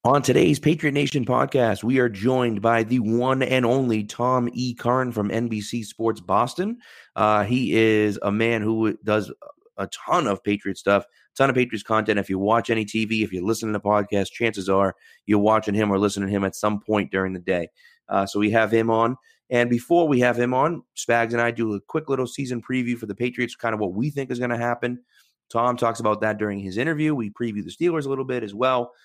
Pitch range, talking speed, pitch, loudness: 105-125 Hz, 230 wpm, 115 Hz, -23 LUFS